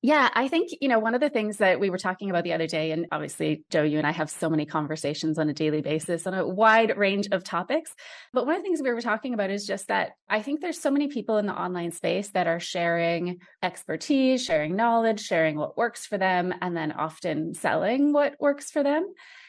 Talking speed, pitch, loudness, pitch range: 240 wpm, 195 Hz, -26 LUFS, 165-260 Hz